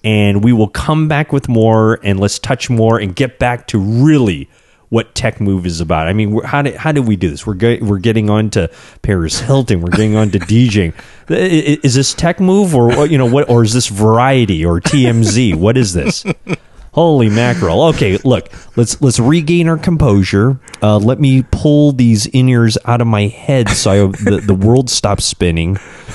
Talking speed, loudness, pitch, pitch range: 200 wpm, -12 LUFS, 115 Hz, 100-135 Hz